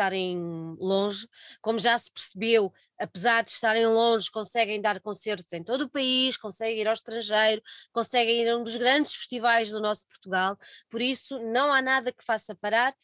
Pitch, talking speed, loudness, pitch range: 225 Hz, 180 wpm, -26 LUFS, 210-240 Hz